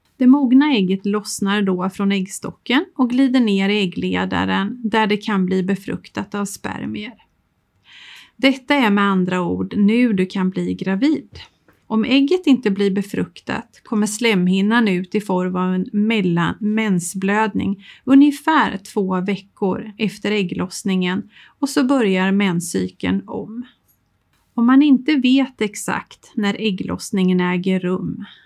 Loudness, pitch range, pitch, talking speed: -18 LUFS, 190-240 Hz, 205 Hz, 130 wpm